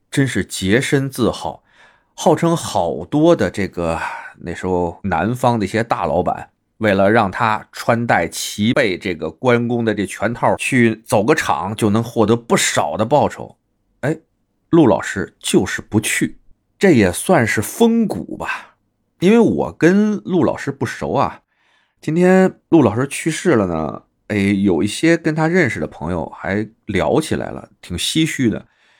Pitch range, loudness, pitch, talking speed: 100-155 Hz, -17 LUFS, 115 Hz, 220 characters per minute